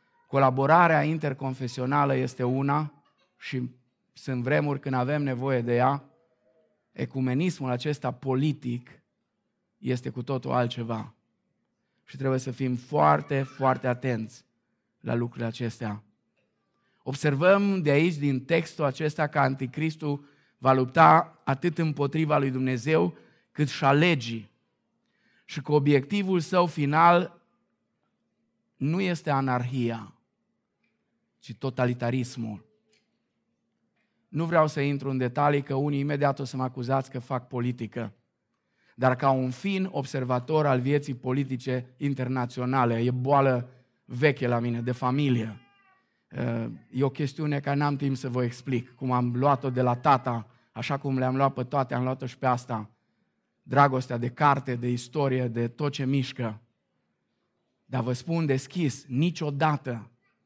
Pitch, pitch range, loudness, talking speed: 135 Hz, 125-145 Hz, -26 LUFS, 130 wpm